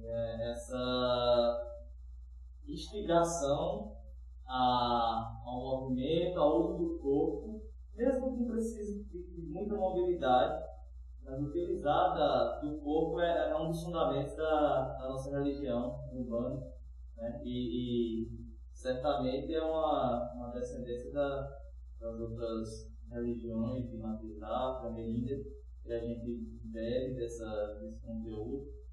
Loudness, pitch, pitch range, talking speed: -35 LUFS, 120 Hz, 115-150 Hz, 105 wpm